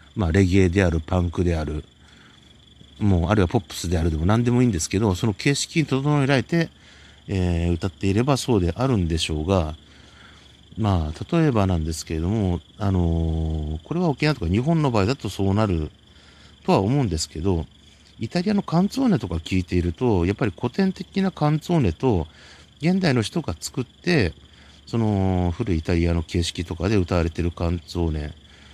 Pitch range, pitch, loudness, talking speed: 80-120 Hz, 95 Hz, -23 LUFS, 370 characters per minute